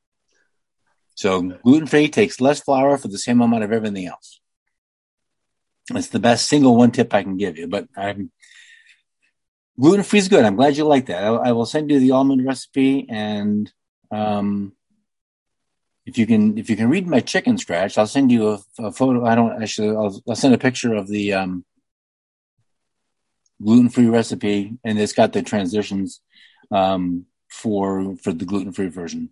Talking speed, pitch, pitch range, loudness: 175 wpm, 115 Hz, 100-140 Hz, -18 LUFS